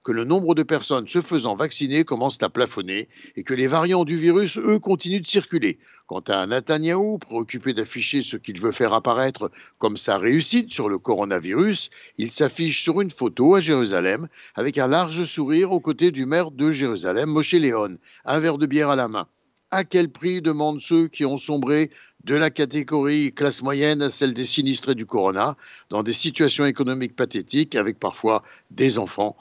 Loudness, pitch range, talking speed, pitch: -22 LUFS, 135-170 Hz, 185 wpm, 150 Hz